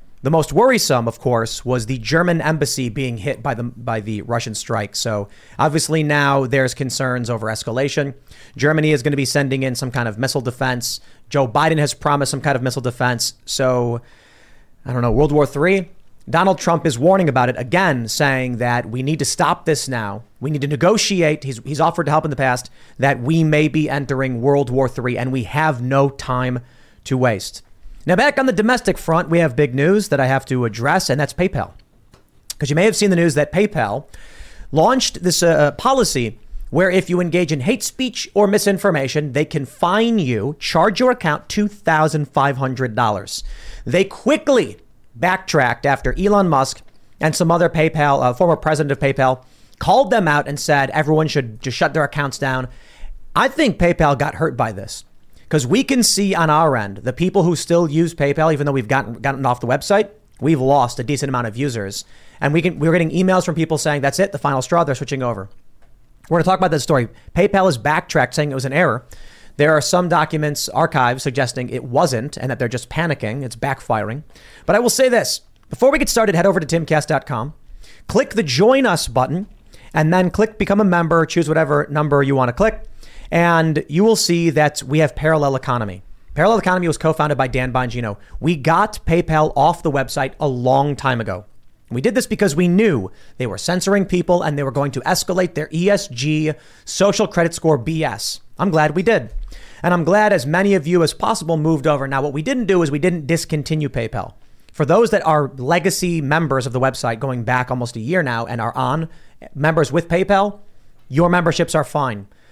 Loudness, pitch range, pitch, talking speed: -17 LUFS, 130-170 Hz, 150 Hz, 205 wpm